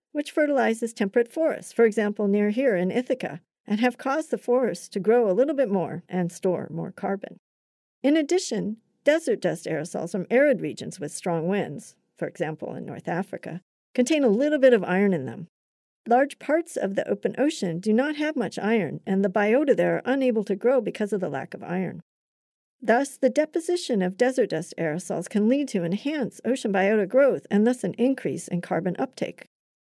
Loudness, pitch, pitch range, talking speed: -25 LUFS, 225 Hz, 190-265 Hz, 190 wpm